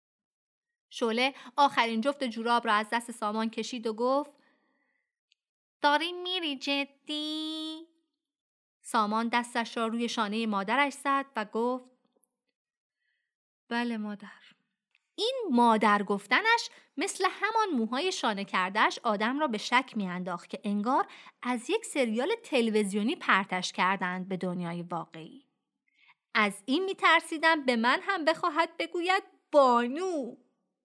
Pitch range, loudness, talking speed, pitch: 220-310 Hz, -29 LUFS, 115 wpm, 250 Hz